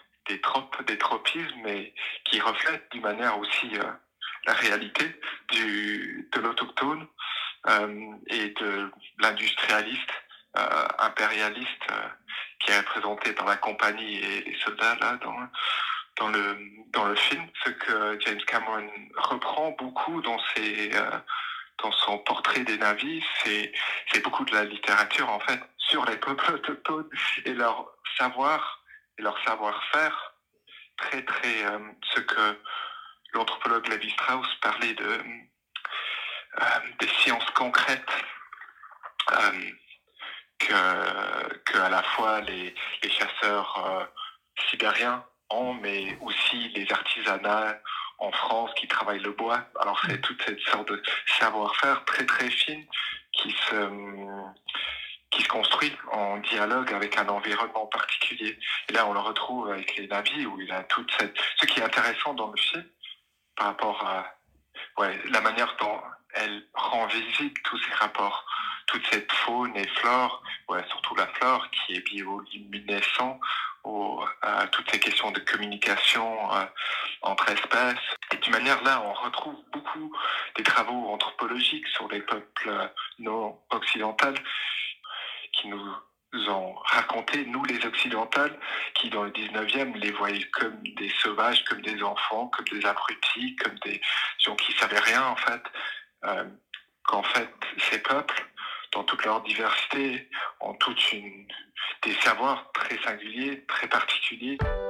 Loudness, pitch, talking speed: -27 LUFS, 110 Hz, 140 wpm